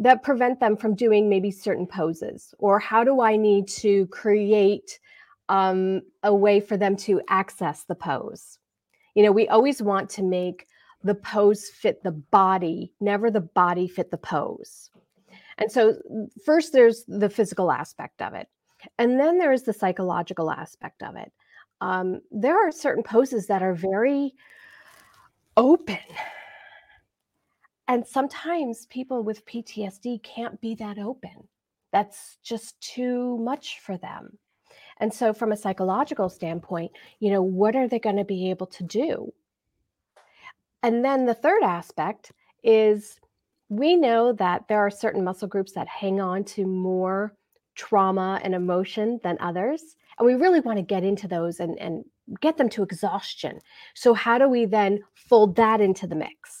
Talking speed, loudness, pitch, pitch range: 155 wpm, -23 LUFS, 210 Hz, 190-240 Hz